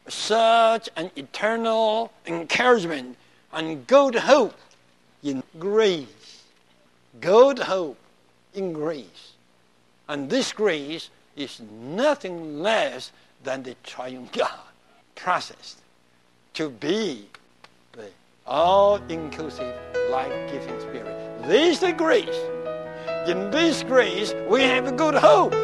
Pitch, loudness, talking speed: 160 Hz, -22 LUFS, 95 wpm